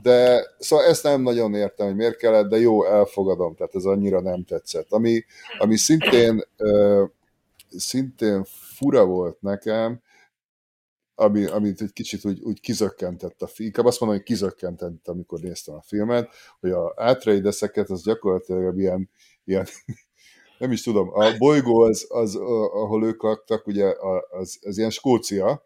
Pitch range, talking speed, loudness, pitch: 100-115 Hz, 150 wpm, -21 LUFS, 105 Hz